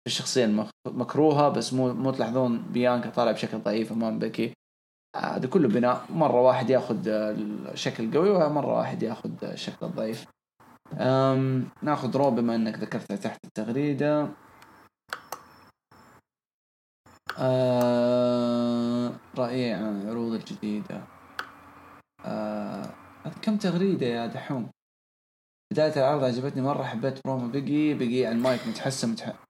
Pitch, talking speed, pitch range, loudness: 125 Hz, 110 wpm, 115-135 Hz, -27 LUFS